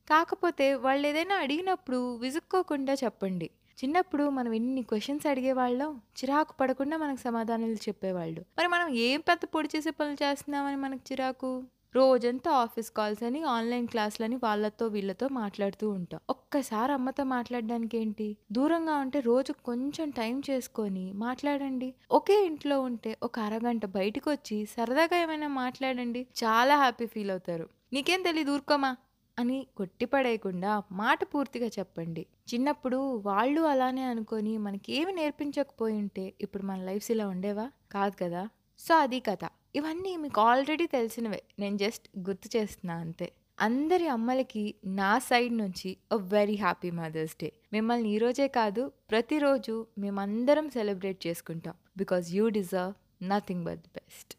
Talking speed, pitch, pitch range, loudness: 130 wpm, 240 Hz, 210-280 Hz, -30 LUFS